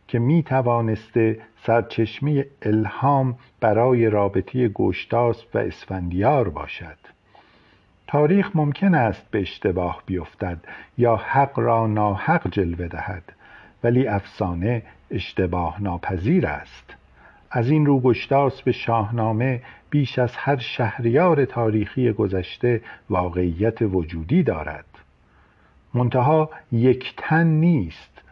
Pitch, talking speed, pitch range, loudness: 115 Hz, 100 wpm, 100-130 Hz, -22 LUFS